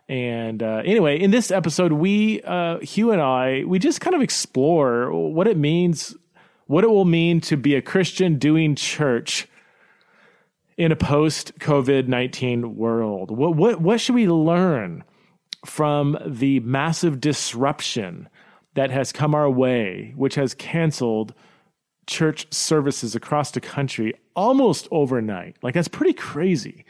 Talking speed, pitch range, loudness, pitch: 145 wpm, 130-180 Hz, -21 LUFS, 150 Hz